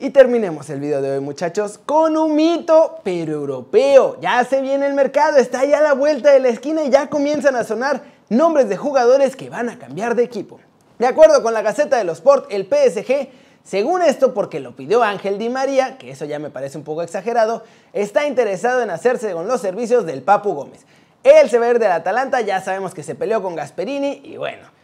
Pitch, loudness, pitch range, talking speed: 245 Hz, -17 LUFS, 195-280 Hz, 220 wpm